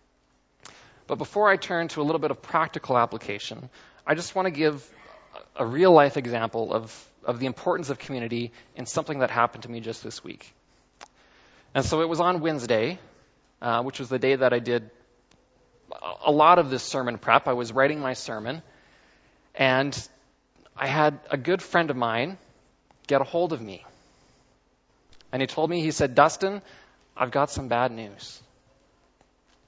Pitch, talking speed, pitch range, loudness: 135 Hz, 170 wpm, 120-160 Hz, -25 LUFS